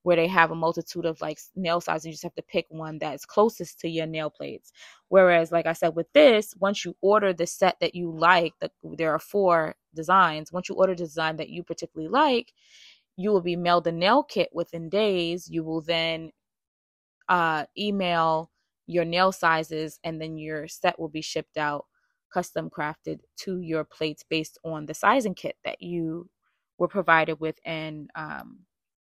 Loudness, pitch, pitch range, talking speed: -25 LUFS, 170 Hz, 160-185 Hz, 190 wpm